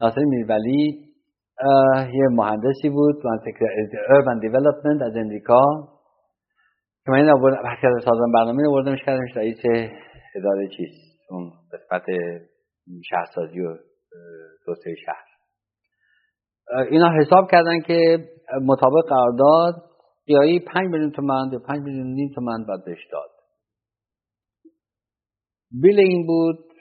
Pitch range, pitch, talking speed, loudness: 115-150 Hz, 135 Hz, 105 wpm, -19 LUFS